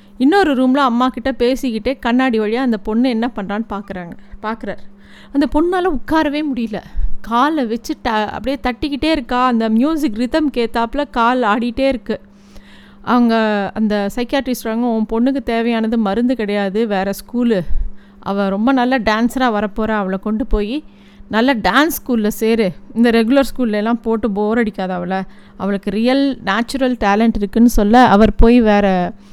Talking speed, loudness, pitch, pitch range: 140 wpm, -16 LUFS, 230 Hz, 210-255 Hz